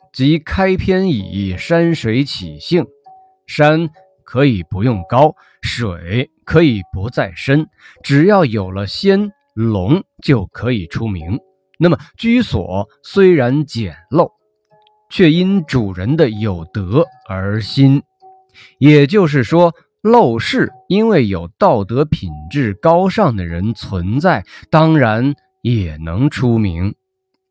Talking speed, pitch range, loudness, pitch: 160 characters per minute, 110-180 Hz, -15 LUFS, 140 Hz